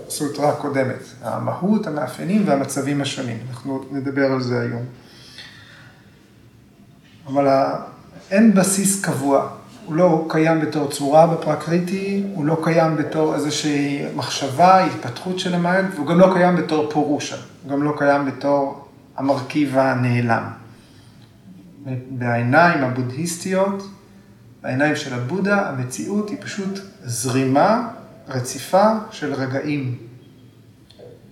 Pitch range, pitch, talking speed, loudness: 130-170 Hz, 145 Hz, 105 wpm, -20 LUFS